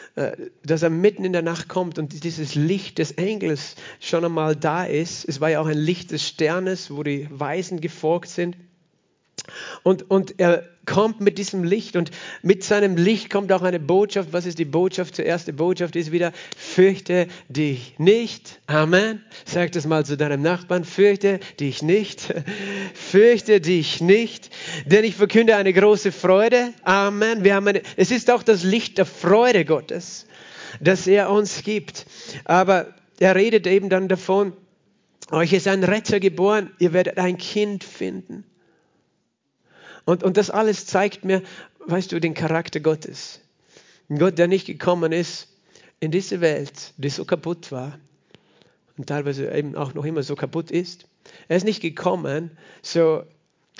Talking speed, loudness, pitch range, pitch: 165 wpm, -21 LUFS, 165-195 Hz, 180 Hz